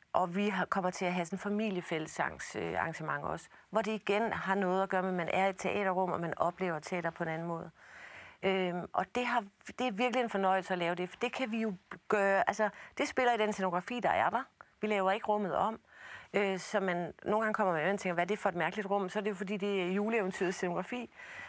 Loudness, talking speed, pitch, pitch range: -34 LUFS, 250 wpm, 195 Hz, 180-215 Hz